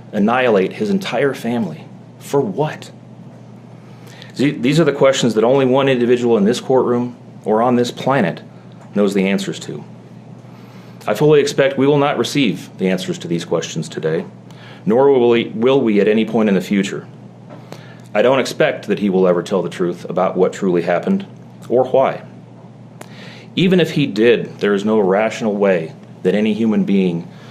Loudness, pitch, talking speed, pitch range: -16 LUFS, 115 Hz, 170 wpm, 95-140 Hz